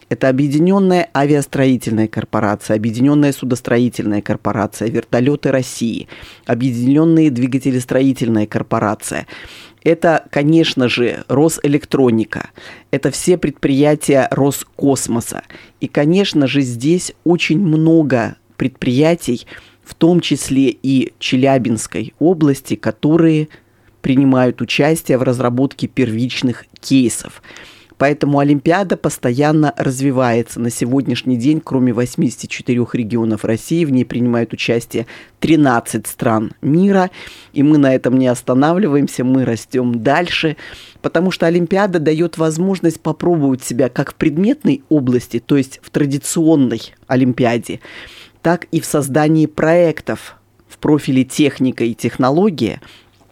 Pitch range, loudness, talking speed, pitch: 120-155 Hz, -15 LUFS, 105 wpm, 135 Hz